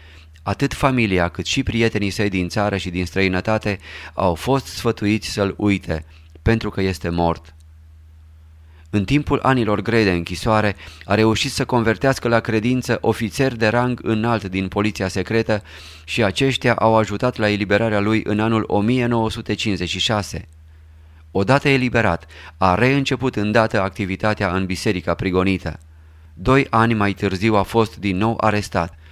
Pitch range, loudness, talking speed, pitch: 90-115 Hz, -19 LUFS, 140 wpm, 105 Hz